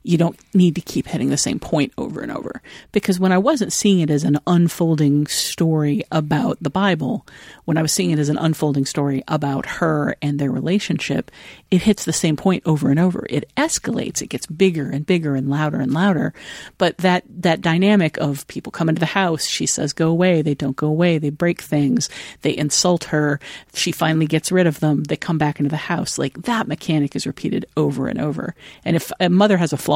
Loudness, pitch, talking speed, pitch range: -19 LUFS, 160 Hz, 220 wpm, 150-180 Hz